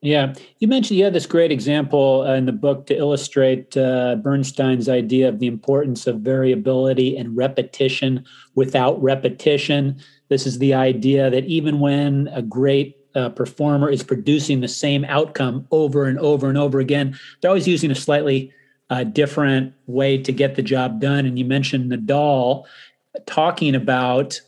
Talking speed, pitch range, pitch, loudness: 165 wpm, 130-145 Hz, 135 Hz, -19 LUFS